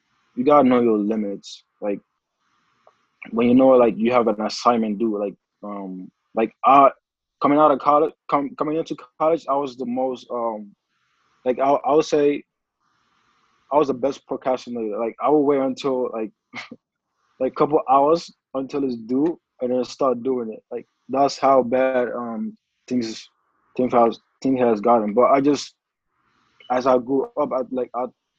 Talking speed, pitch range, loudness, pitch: 170 wpm, 115-140 Hz, -21 LUFS, 125 Hz